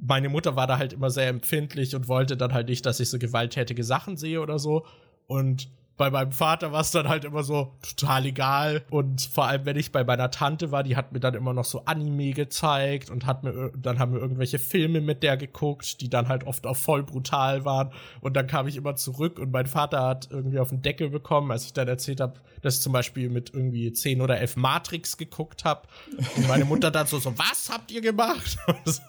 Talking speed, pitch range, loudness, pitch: 235 wpm, 130-150 Hz, -26 LUFS, 135 Hz